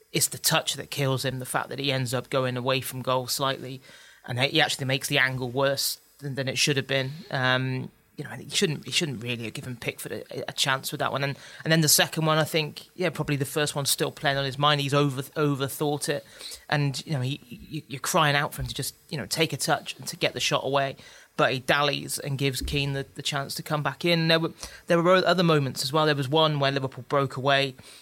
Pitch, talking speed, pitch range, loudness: 140 Hz, 260 wpm, 135-150 Hz, -25 LUFS